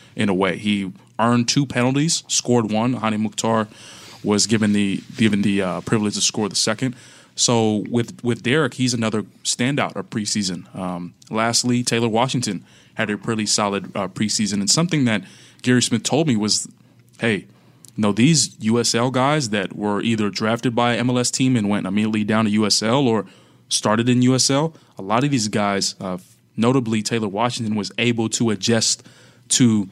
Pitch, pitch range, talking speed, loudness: 115 Hz, 105-125 Hz, 175 wpm, -20 LUFS